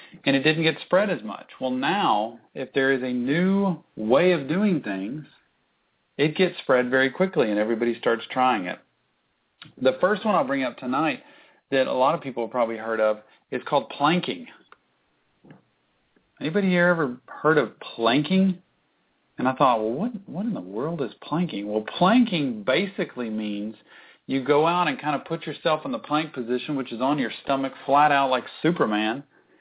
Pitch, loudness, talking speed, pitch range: 140 Hz, -24 LUFS, 180 wpm, 125-175 Hz